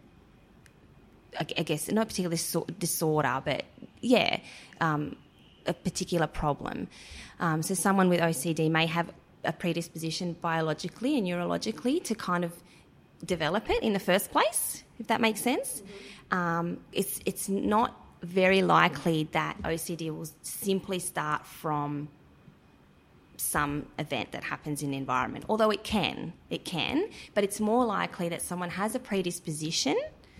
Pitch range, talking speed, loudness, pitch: 160-195 Hz, 140 wpm, -29 LUFS, 175 Hz